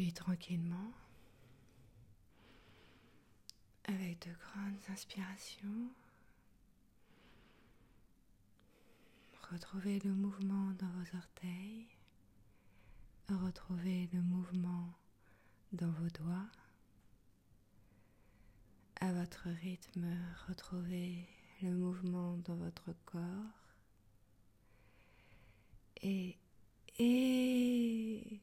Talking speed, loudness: 60 wpm, -41 LUFS